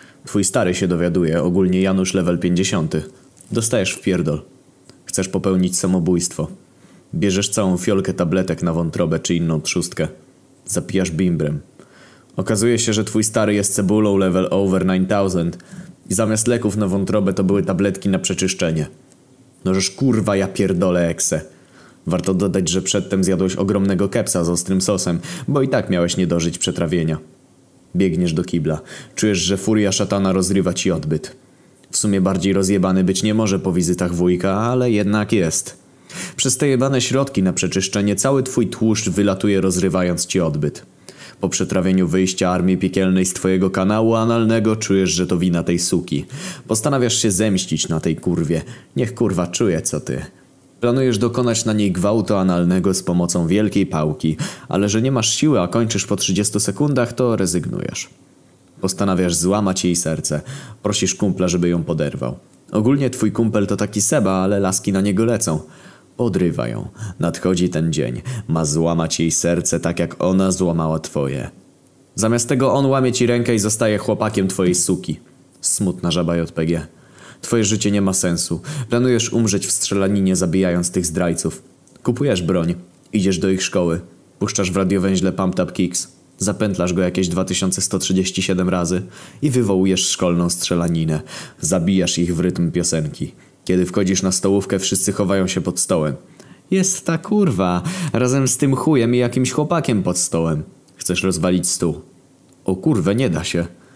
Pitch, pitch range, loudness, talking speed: 95 Hz, 90-110 Hz, -18 LUFS, 155 wpm